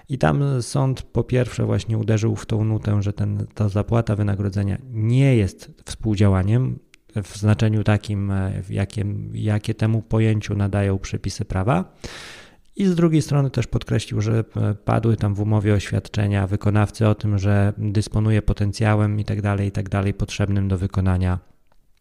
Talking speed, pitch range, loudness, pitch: 140 wpm, 100-110 Hz, -21 LUFS, 105 Hz